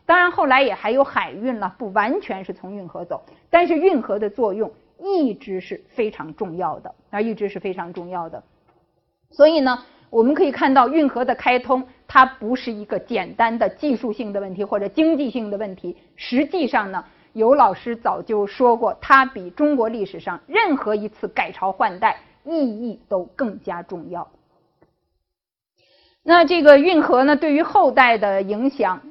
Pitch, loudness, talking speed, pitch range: 235 Hz, -19 LUFS, 255 characters per minute, 200-285 Hz